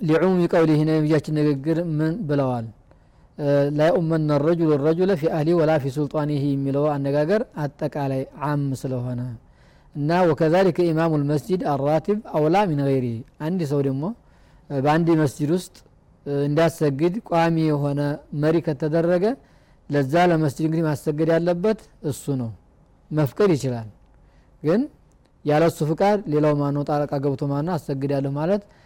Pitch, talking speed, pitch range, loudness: 155 Hz, 120 wpm, 145-165 Hz, -22 LUFS